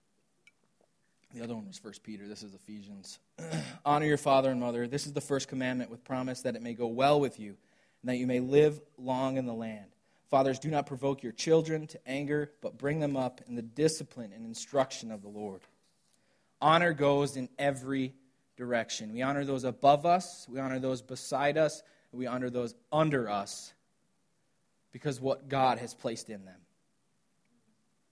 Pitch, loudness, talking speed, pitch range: 130 Hz, -31 LUFS, 180 wpm, 120-145 Hz